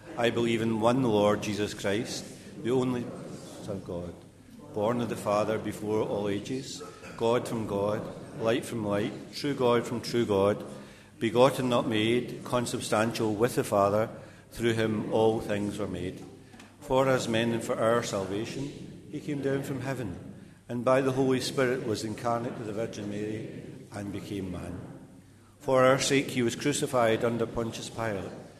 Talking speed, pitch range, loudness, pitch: 165 wpm, 105-125 Hz, -29 LUFS, 115 Hz